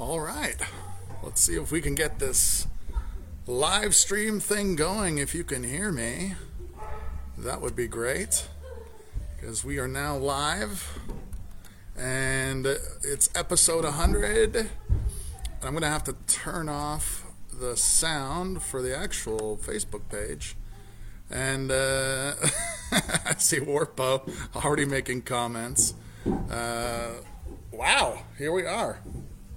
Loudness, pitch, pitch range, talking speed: -27 LUFS, 120 Hz, 95-145 Hz, 120 wpm